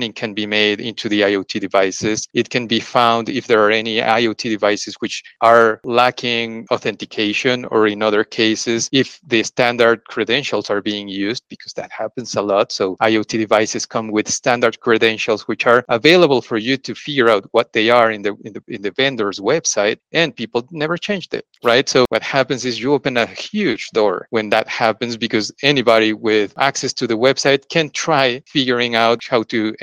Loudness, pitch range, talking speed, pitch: -17 LUFS, 110-125 Hz, 190 wpm, 115 Hz